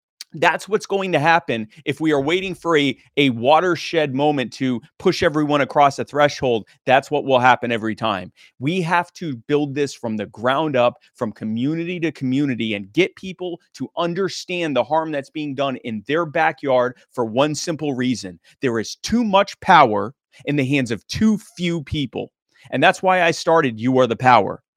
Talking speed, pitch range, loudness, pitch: 185 wpm, 125-170 Hz, -19 LUFS, 145 Hz